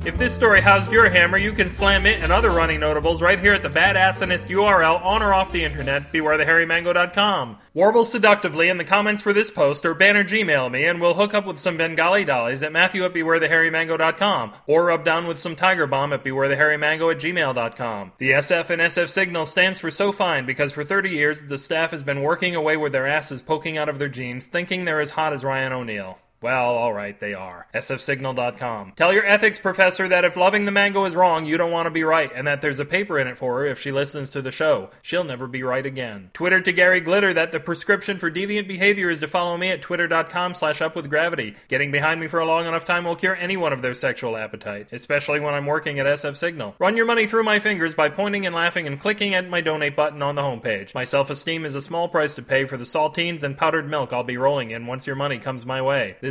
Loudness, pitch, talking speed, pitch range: -20 LUFS, 160 Hz, 235 wpm, 140-180 Hz